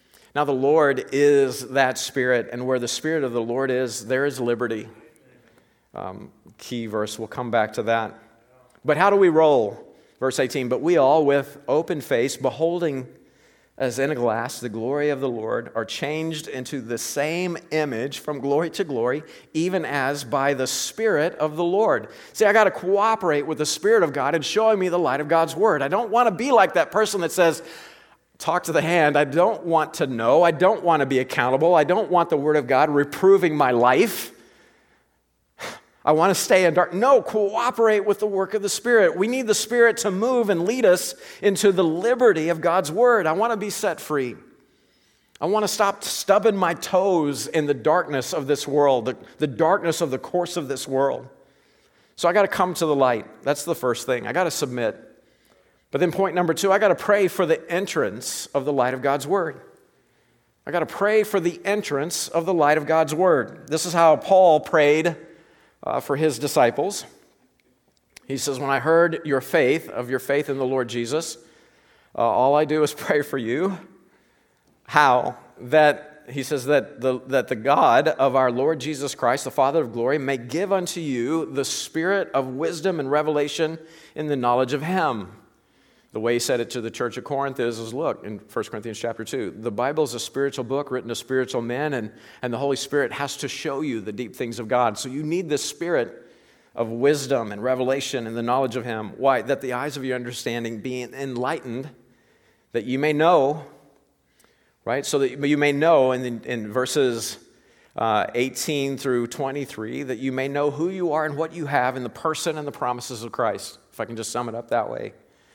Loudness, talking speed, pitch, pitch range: -22 LUFS, 205 wpm, 145 Hz, 130-170 Hz